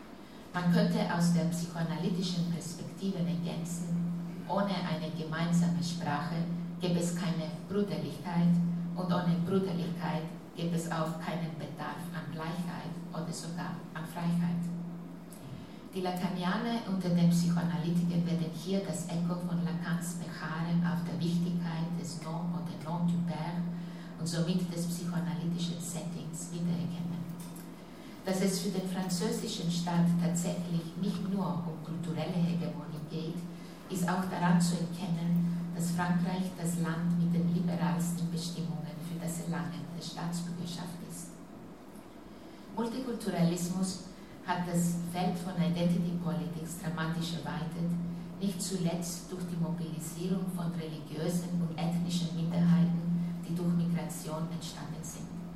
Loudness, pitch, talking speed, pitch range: -33 LUFS, 175 Hz, 120 wpm, 170-175 Hz